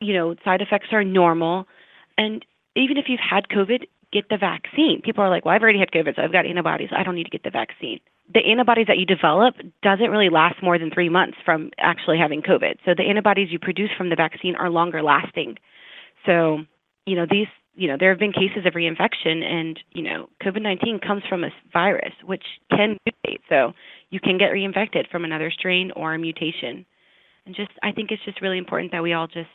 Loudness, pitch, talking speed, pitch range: -21 LUFS, 190 Hz, 220 wpm, 170-210 Hz